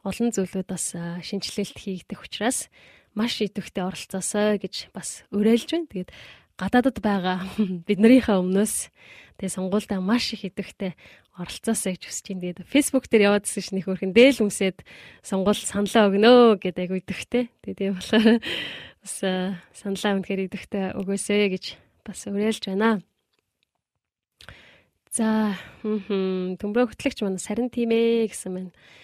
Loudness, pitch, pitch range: -24 LUFS, 200 Hz, 190-220 Hz